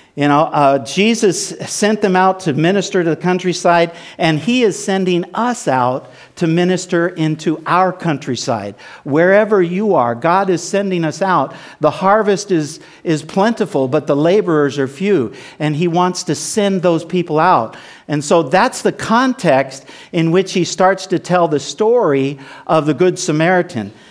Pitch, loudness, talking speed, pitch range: 175 Hz, -15 LUFS, 165 wpm, 150-190 Hz